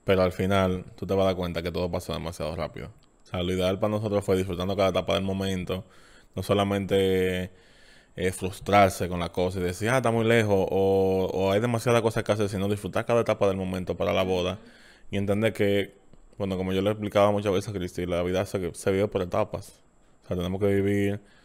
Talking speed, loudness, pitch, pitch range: 220 wpm, -26 LUFS, 95 Hz, 90-100 Hz